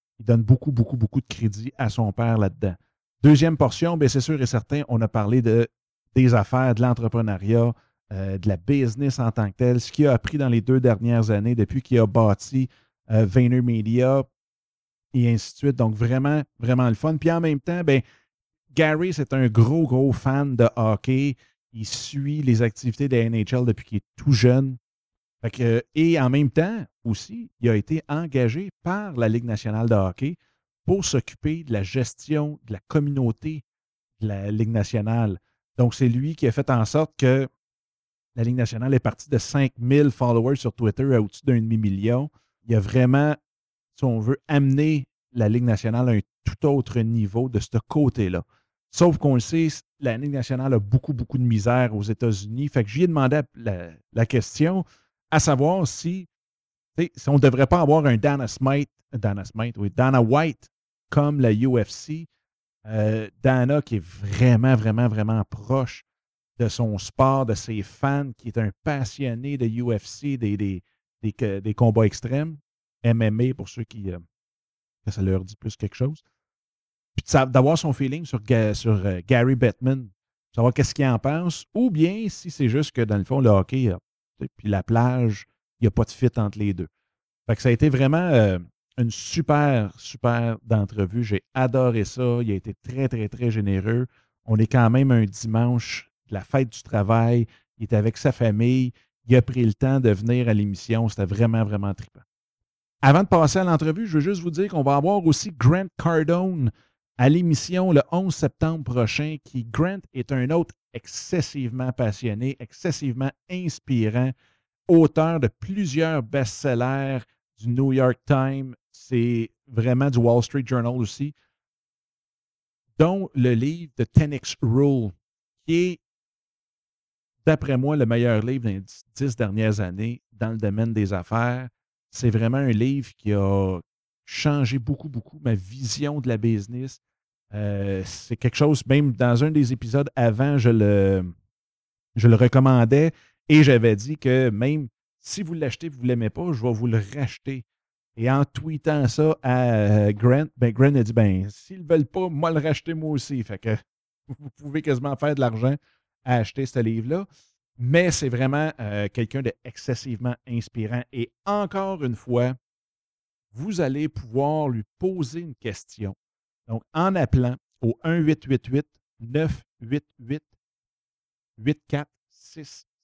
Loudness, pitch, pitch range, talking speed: -22 LUFS, 125 Hz, 110-140 Hz, 170 wpm